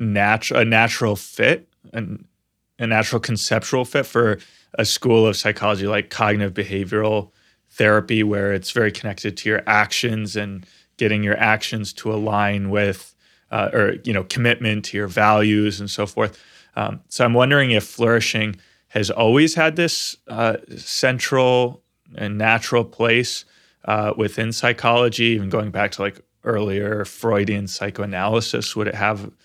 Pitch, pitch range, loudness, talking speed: 105 Hz, 105-115 Hz, -19 LUFS, 145 wpm